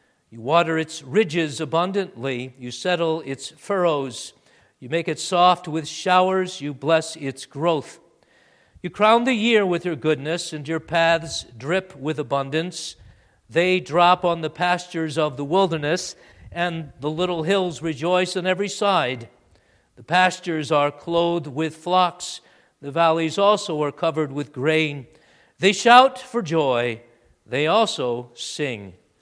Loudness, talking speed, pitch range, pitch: -21 LUFS, 140 wpm, 145-180 Hz, 160 Hz